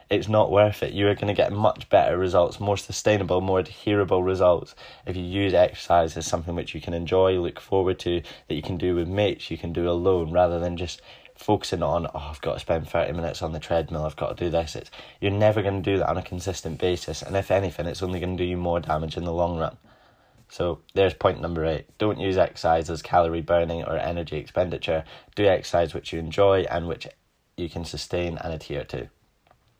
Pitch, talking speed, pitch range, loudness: 90 Hz, 230 wpm, 85-95 Hz, -25 LUFS